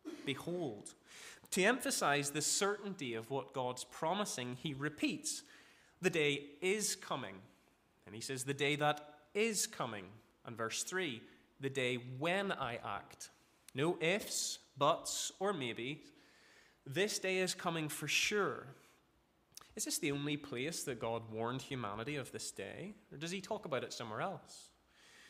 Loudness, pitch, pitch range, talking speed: -38 LUFS, 150 Hz, 130-190 Hz, 145 wpm